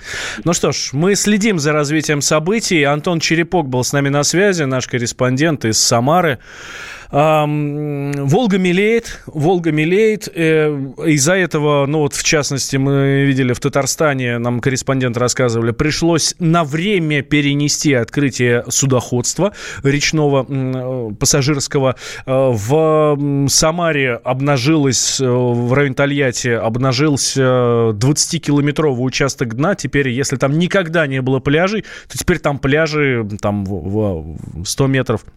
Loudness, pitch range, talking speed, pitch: -15 LUFS, 130-155 Hz, 115 wpm, 140 Hz